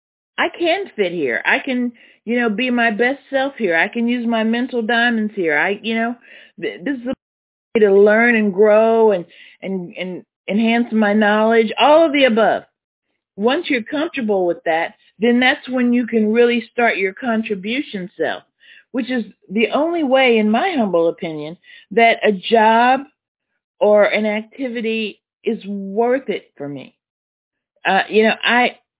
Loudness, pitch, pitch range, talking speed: -17 LUFS, 230 Hz, 210-245 Hz, 165 wpm